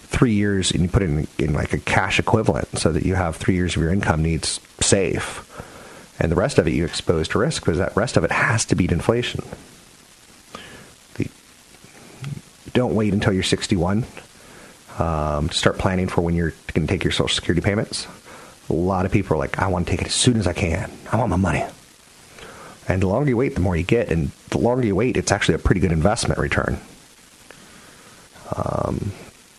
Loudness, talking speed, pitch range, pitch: -21 LUFS, 210 wpm, 85-105 Hz, 95 Hz